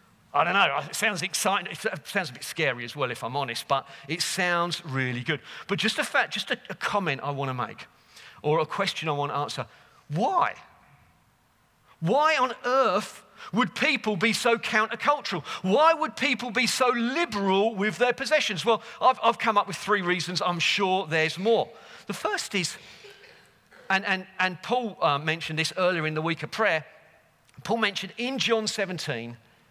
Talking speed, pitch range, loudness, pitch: 180 wpm, 155-230 Hz, -26 LUFS, 190 Hz